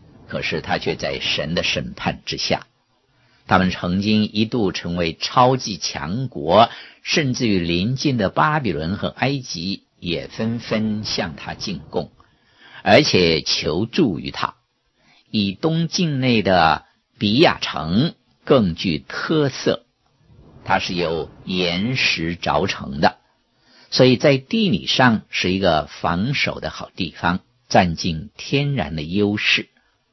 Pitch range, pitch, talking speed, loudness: 90-130 Hz, 110 Hz, 180 characters per minute, -20 LUFS